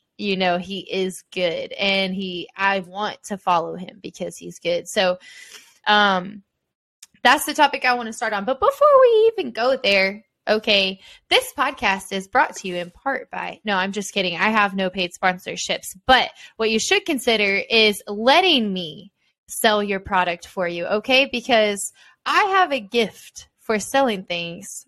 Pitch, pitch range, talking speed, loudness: 205 Hz, 190-250 Hz, 175 wpm, -20 LUFS